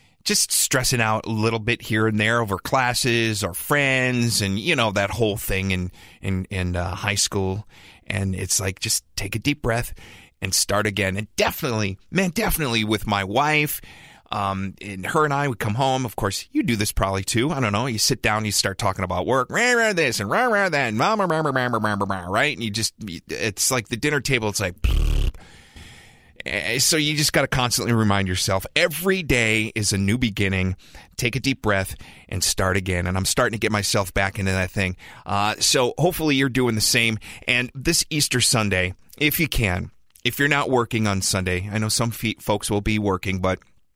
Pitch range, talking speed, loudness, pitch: 95-130 Hz, 210 wpm, -21 LUFS, 110 Hz